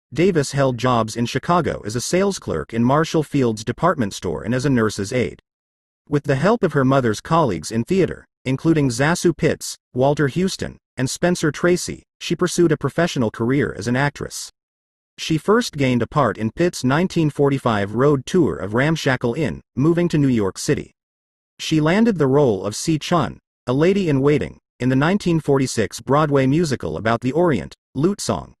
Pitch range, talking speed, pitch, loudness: 120-165 Hz, 170 wpm, 140 Hz, -19 LUFS